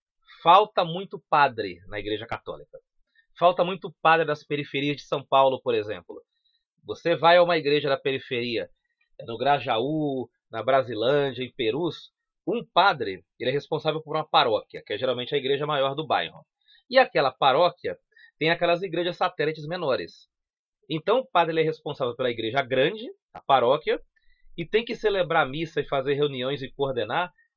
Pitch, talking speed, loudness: 170 Hz, 160 wpm, -25 LUFS